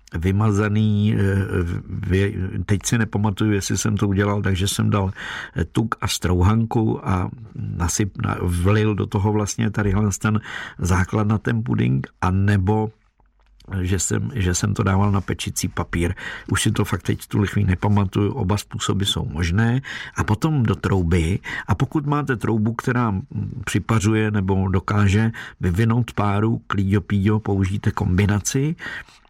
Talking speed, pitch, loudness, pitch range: 135 wpm, 105 Hz, -21 LUFS, 95-110 Hz